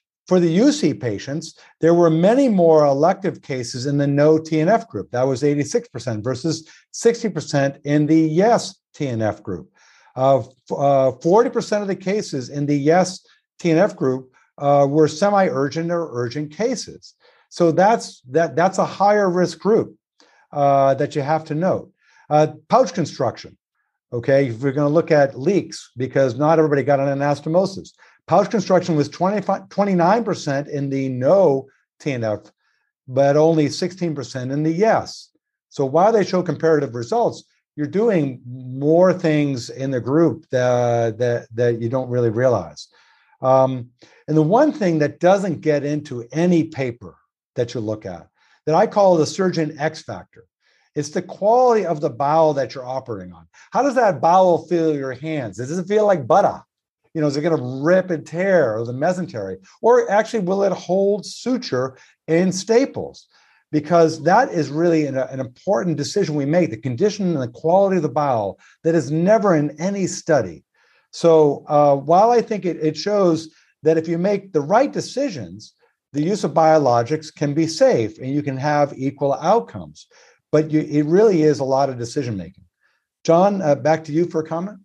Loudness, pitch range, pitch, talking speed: -19 LUFS, 135-180 Hz, 155 Hz, 170 wpm